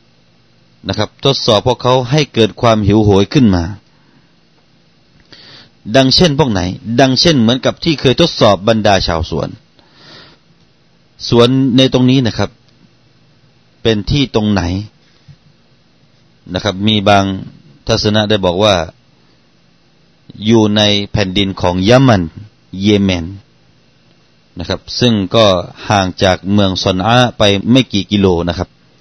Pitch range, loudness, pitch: 95-125 Hz, -12 LUFS, 105 Hz